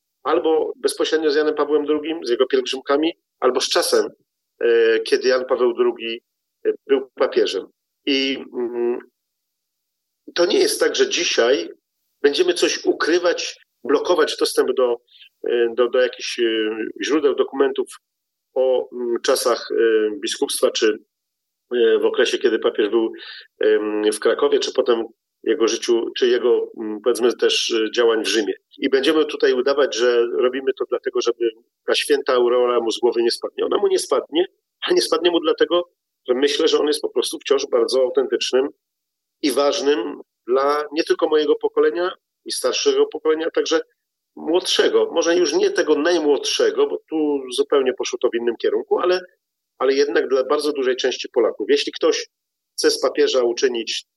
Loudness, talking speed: -19 LUFS, 150 wpm